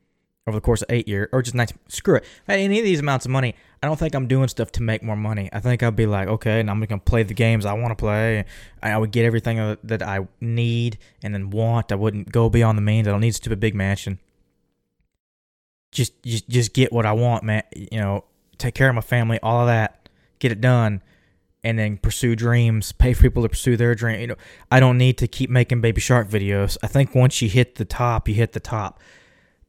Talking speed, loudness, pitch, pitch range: 245 wpm, -21 LUFS, 115 Hz, 105-120 Hz